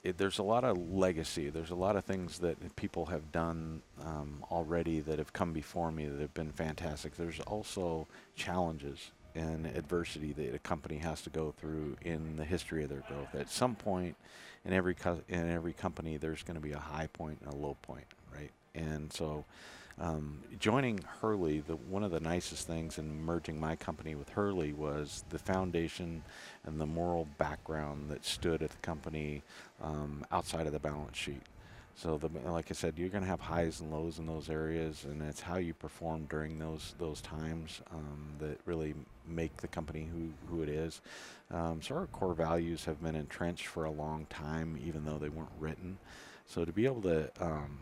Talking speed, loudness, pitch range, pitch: 195 wpm, -38 LUFS, 75-85 Hz, 80 Hz